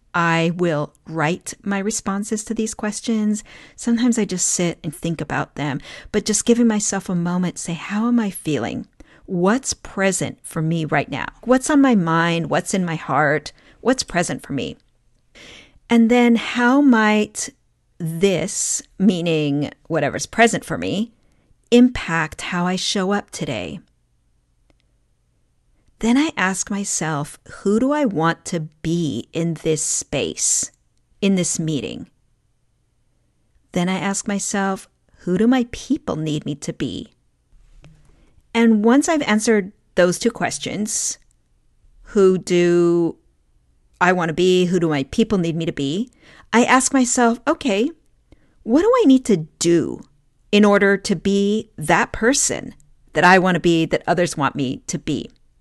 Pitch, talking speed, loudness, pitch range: 190 Hz, 150 wpm, -19 LUFS, 165-225 Hz